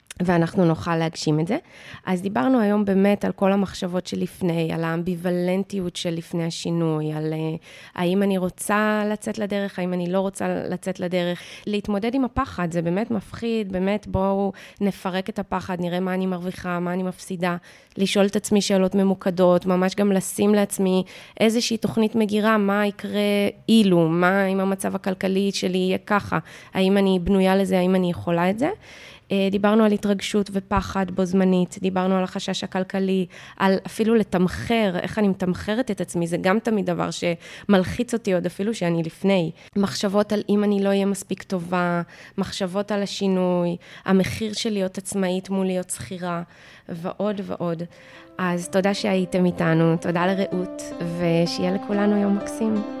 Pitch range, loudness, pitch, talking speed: 180-205 Hz, -23 LUFS, 190 Hz, 155 wpm